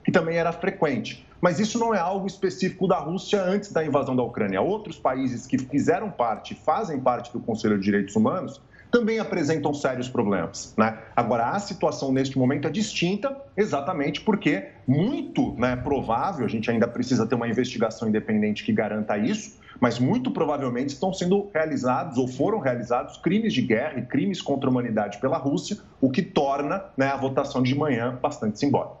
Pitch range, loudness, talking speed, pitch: 125-195 Hz, -25 LUFS, 180 wpm, 145 Hz